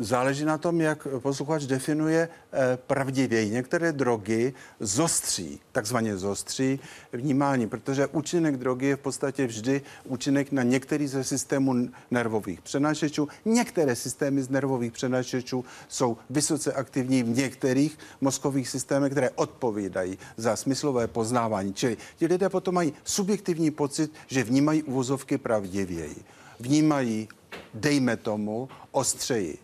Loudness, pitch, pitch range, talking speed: -27 LUFS, 135 Hz, 125-150 Hz, 120 wpm